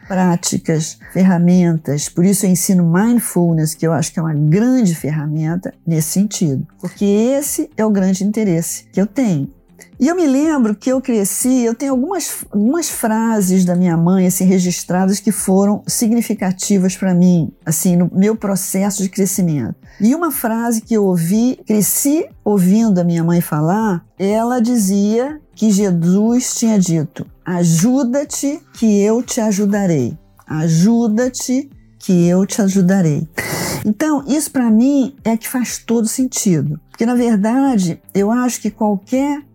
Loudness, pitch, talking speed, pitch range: -15 LUFS, 200 Hz, 150 wpm, 175-235 Hz